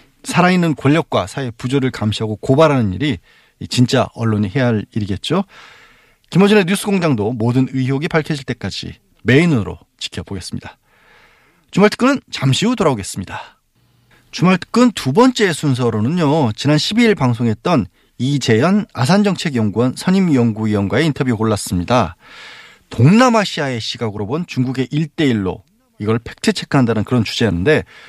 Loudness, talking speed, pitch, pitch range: -16 LUFS, 340 characters per minute, 130 Hz, 110-170 Hz